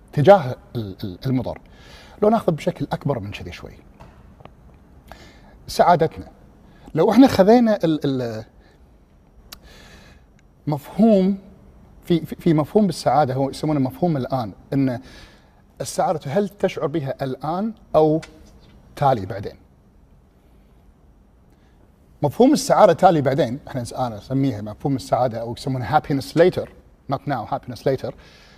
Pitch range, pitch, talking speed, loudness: 105-165 Hz, 135 Hz, 100 wpm, -20 LUFS